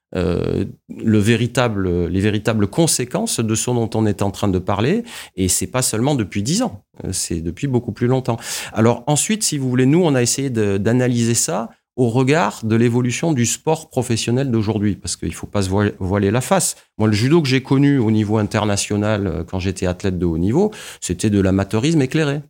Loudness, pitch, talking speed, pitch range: -18 LUFS, 115 Hz, 200 wpm, 100-130 Hz